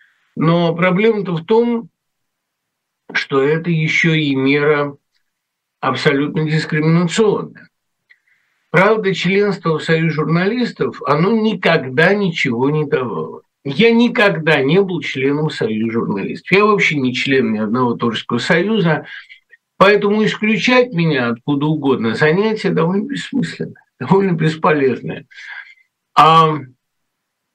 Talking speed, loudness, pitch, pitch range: 100 wpm, -15 LUFS, 165 Hz, 145-205 Hz